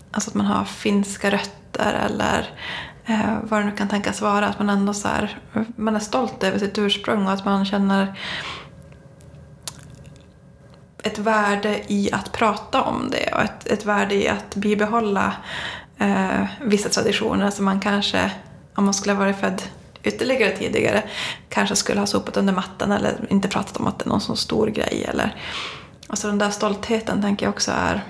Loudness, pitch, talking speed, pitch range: -22 LUFS, 205 Hz, 180 wpm, 200-215 Hz